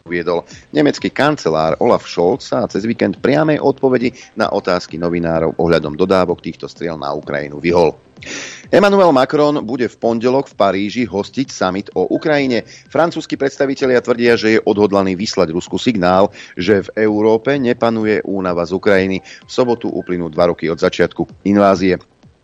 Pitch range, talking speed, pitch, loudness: 90-130 Hz, 145 wpm, 100 Hz, -15 LUFS